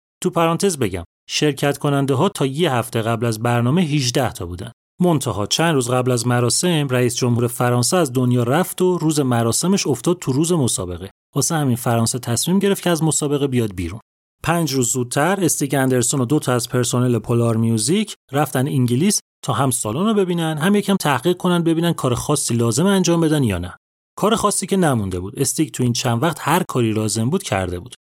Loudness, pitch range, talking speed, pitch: -18 LUFS, 120-170 Hz, 195 wpm, 135 Hz